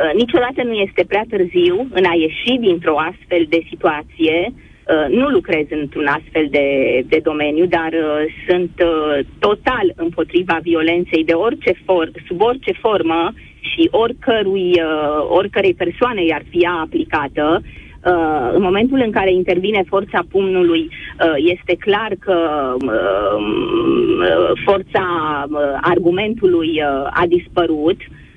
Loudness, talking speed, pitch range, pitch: -16 LUFS, 110 wpm, 160-205 Hz, 175 Hz